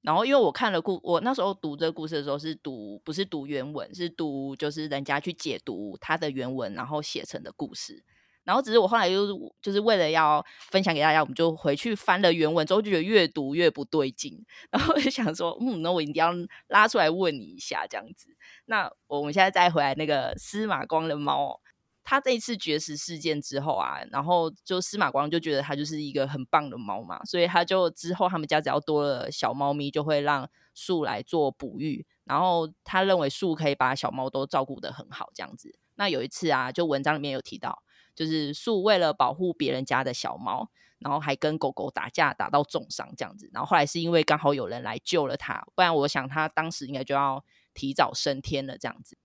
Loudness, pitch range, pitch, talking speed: -27 LUFS, 140-175 Hz, 155 Hz, 330 characters per minute